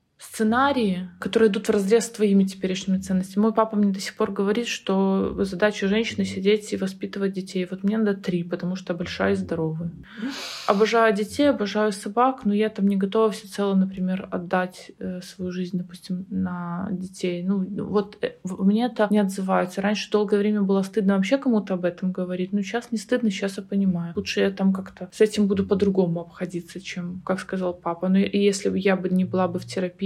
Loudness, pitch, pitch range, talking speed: -24 LUFS, 195 Hz, 185-210 Hz, 200 wpm